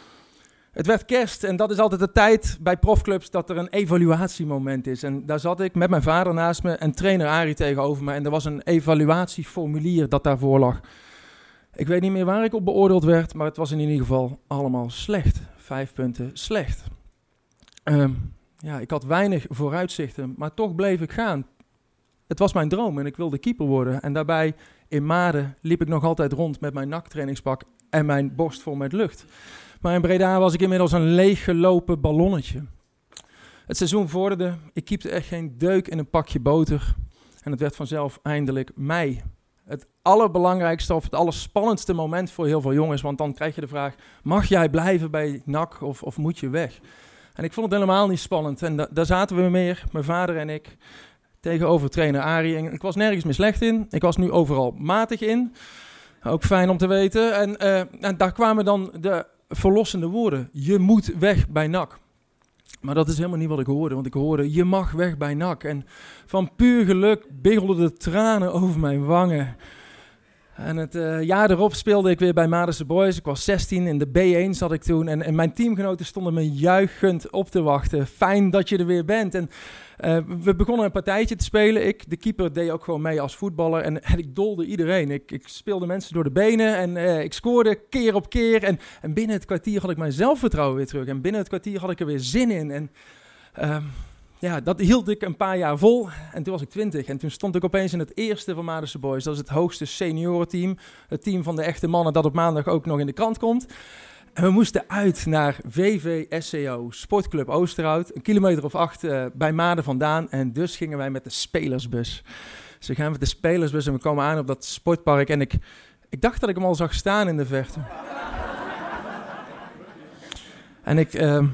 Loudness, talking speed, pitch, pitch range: -22 LUFS, 205 wpm, 170 Hz, 150-190 Hz